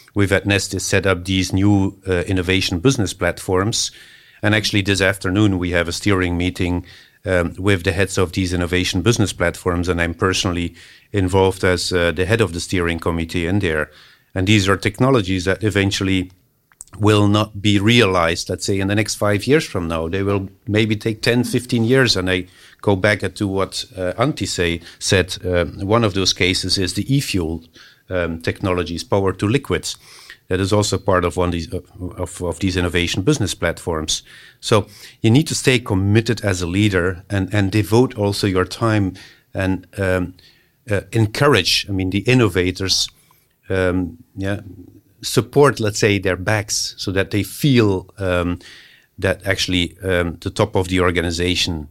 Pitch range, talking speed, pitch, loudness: 90-105 Hz, 175 wpm, 95 Hz, -18 LUFS